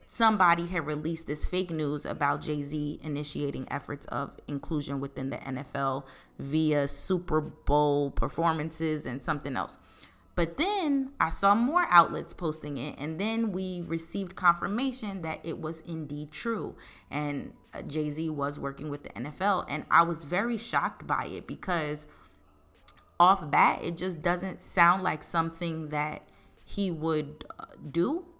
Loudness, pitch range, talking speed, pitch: -29 LUFS, 145-175 Hz, 145 wpm, 155 Hz